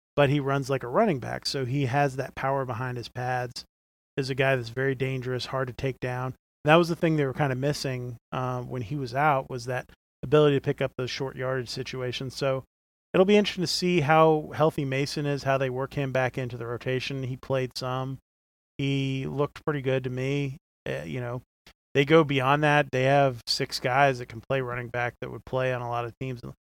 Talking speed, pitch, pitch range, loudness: 225 wpm, 135 Hz, 125-140 Hz, -27 LUFS